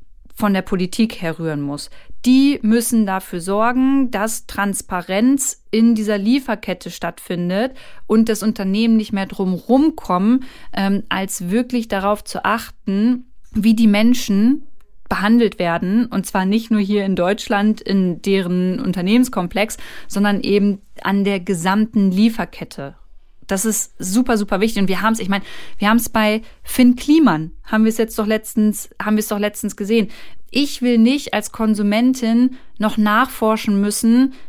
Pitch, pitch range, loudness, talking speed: 215 Hz, 195-230 Hz, -18 LUFS, 150 wpm